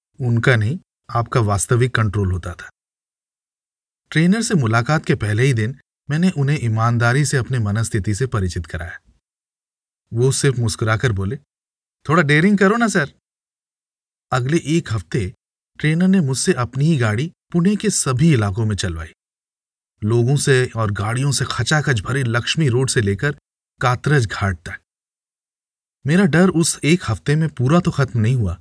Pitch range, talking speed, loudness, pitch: 110-155 Hz, 150 wpm, -18 LUFS, 130 Hz